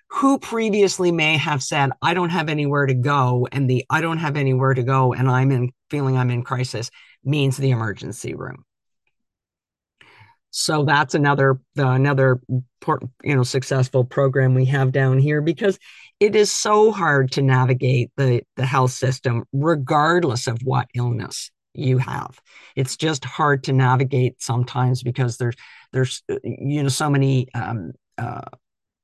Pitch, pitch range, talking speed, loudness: 135 Hz, 130-150 Hz, 155 wpm, -20 LUFS